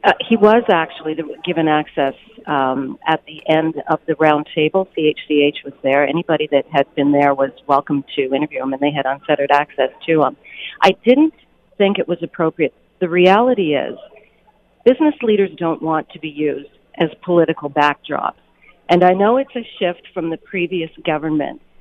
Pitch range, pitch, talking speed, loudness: 145-180 Hz, 160 Hz, 170 wpm, -17 LUFS